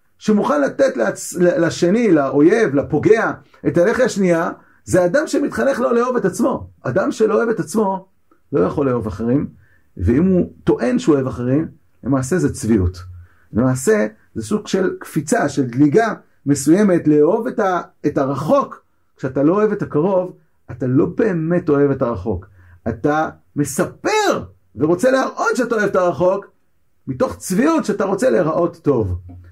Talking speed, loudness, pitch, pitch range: 145 wpm, -17 LUFS, 170 Hz, 130-210 Hz